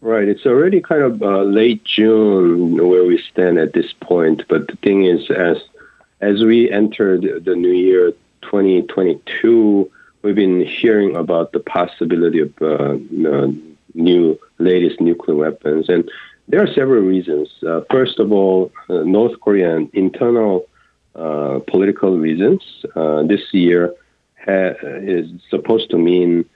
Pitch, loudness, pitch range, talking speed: 95 Hz, -15 LUFS, 85-105 Hz, 140 wpm